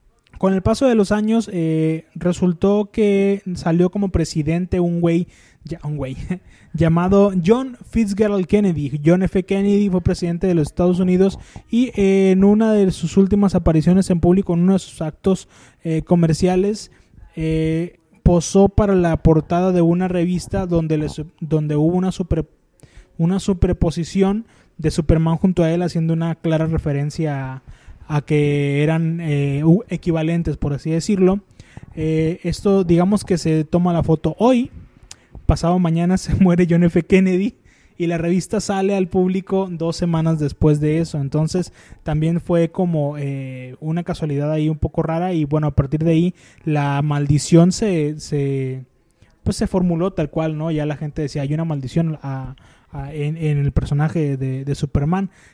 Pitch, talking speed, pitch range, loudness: 170 Hz, 165 wpm, 155-185 Hz, -18 LUFS